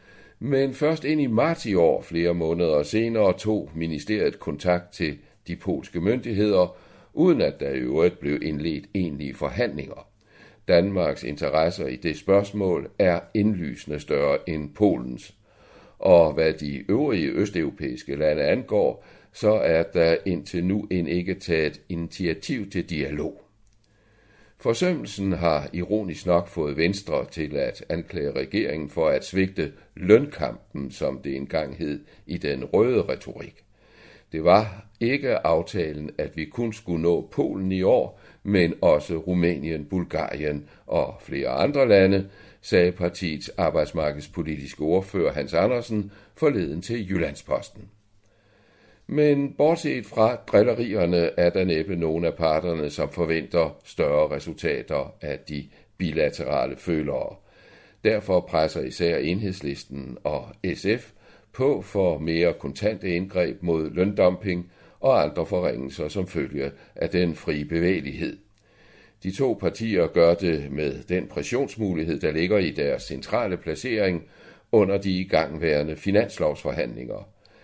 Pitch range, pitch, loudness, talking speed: 80-105 Hz, 90 Hz, -24 LUFS, 125 wpm